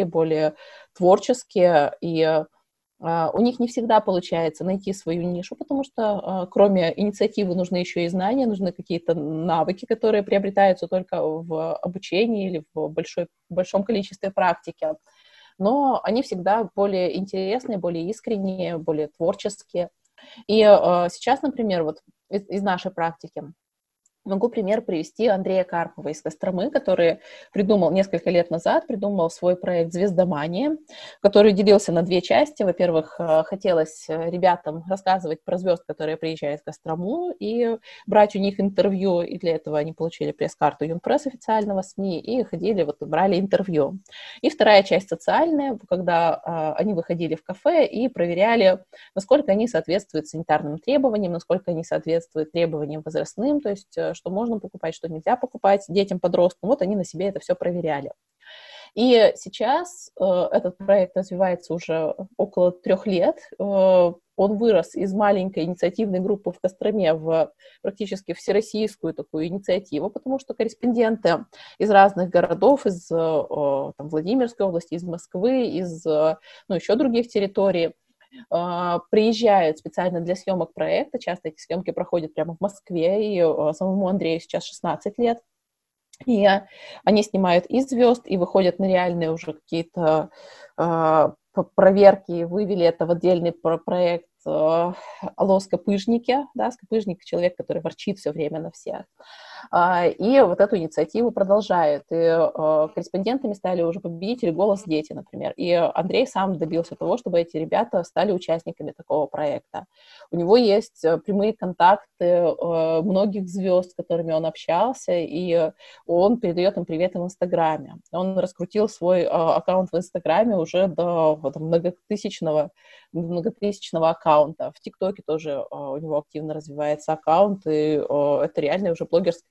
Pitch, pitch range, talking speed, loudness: 185 Hz, 165-205 Hz, 135 wpm, -22 LUFS